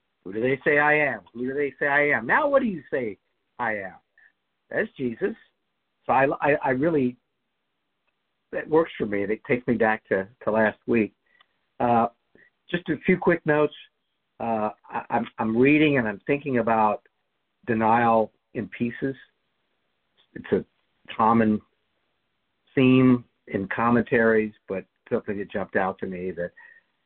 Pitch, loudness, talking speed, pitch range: 125 Hz, -24 LUFS, 155 wpm, 110-145 Hz